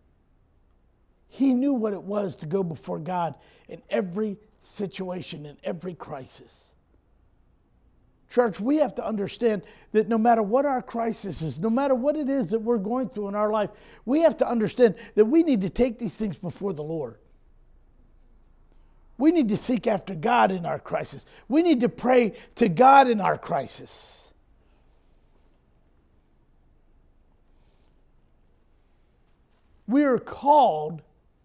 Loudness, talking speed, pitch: -24 LUFS, 140 wpm, 185 Hz